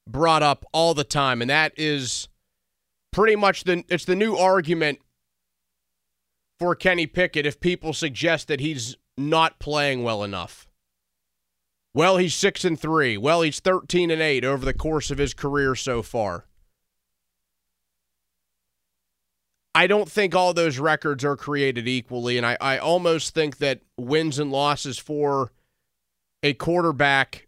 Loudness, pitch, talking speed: -22 LUFS, 140 Hz, 145 wpm